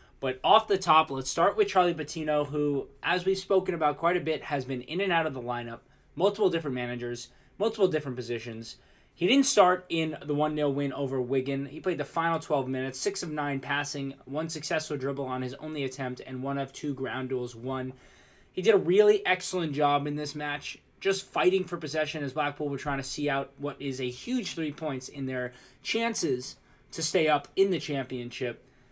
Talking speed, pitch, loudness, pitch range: 205 wpm, 145 Hz, -29 LUFS, 130-170 Hz